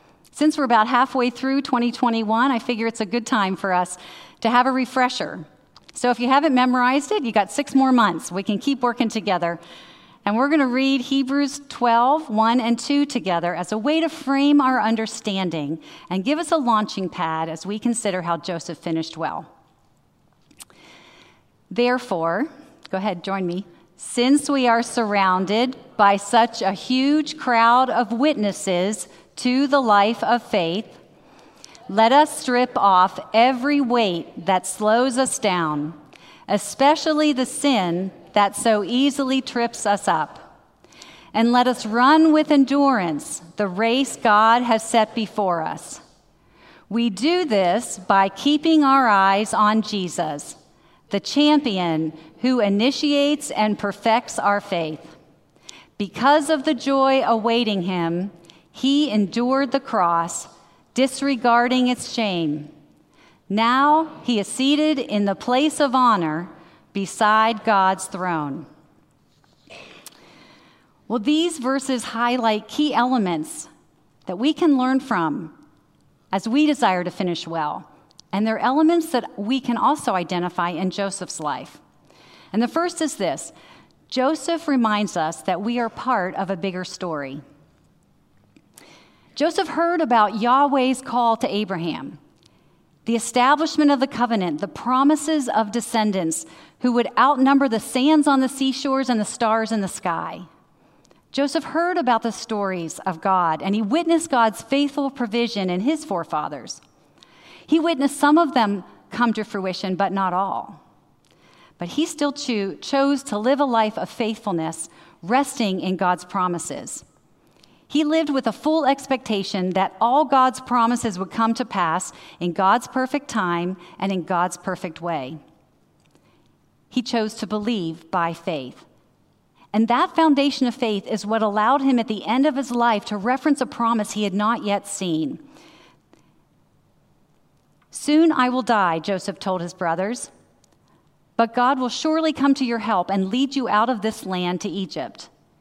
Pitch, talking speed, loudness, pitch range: 230 Hz, 145 wpm, -21 LUFS, 190-265 Hz